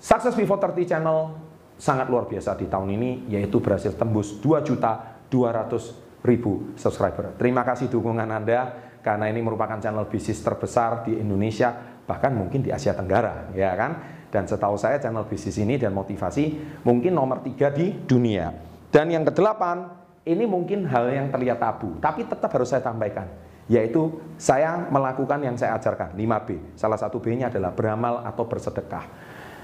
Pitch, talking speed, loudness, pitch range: 120 Hz, 150 wpm, -24 LUFS, 105-145 Hz